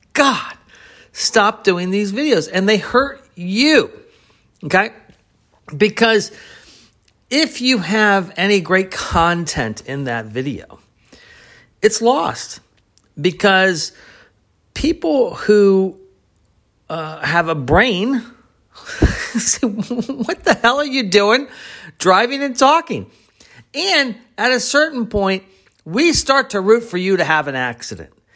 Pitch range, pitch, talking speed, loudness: 175-255 Hz, 210 Hz, 115 wpm, -16 LUFS